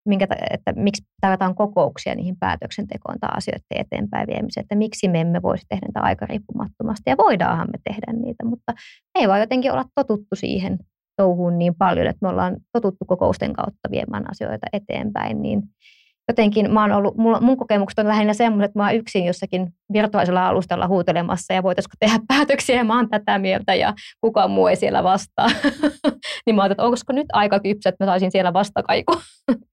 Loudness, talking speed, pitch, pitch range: -20 LUFS, 180 wpm, 210 Hz, 195-235 Hz